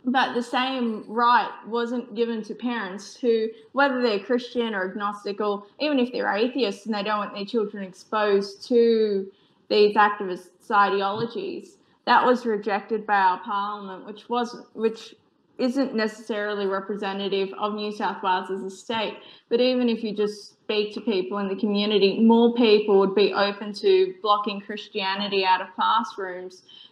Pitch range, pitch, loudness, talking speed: 200-235 Hz, 210 Hz, -24 LUFS, 160 wpm